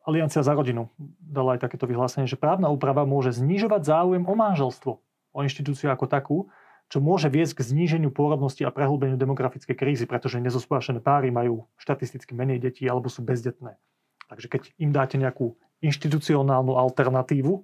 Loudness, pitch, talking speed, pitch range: -25 LUFS, 135 Hz, 155 wpm, 130-150 Hz